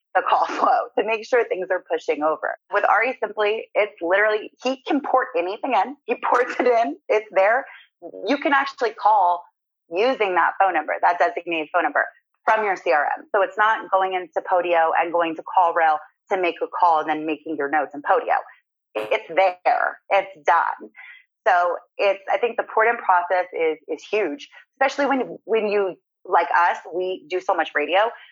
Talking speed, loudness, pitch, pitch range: 185 wpm, -21 LUFS, 195 Hz, 175-240 Hz